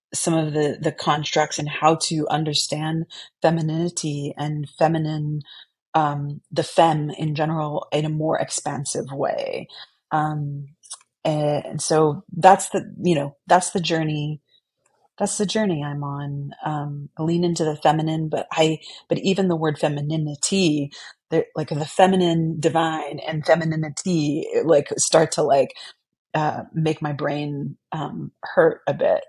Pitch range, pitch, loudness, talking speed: 150-165 Hz, 155 Hz, -22 LUFS, 140 wpm